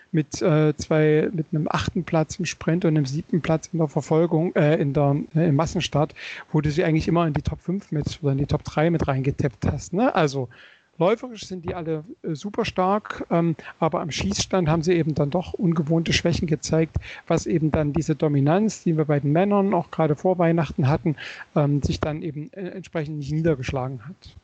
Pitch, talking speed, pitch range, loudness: 160 Hz, 205 wpm, 150-175 Hz, -23 LUFS